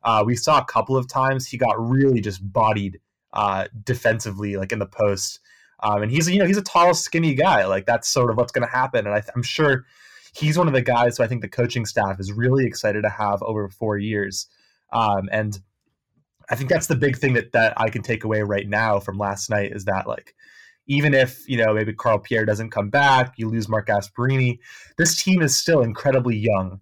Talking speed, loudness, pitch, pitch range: 225 wpm, -21 LUFS, 115 Hz, 105-135 Hz